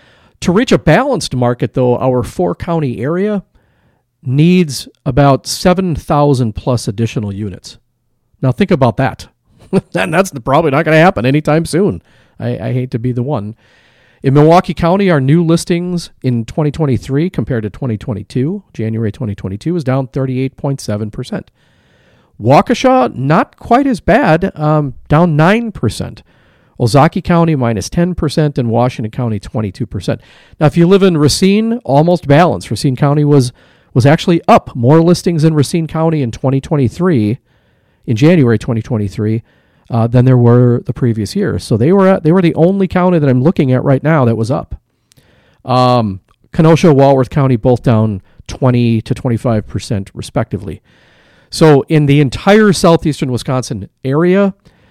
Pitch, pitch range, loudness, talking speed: 135 Hz, 120-165 Hz, -12 LUFS, 160 wpm